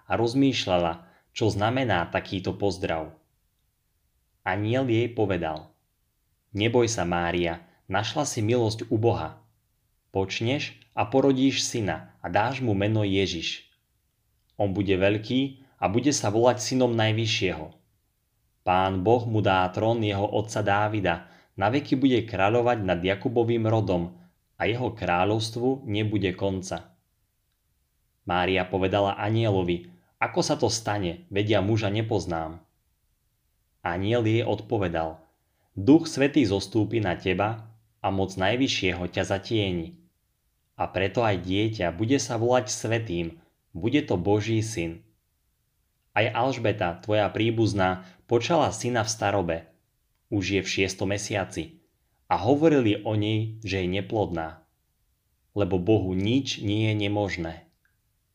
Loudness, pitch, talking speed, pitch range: -26 LUFS, 105 Hz, 120 wpm, 95-115 Hz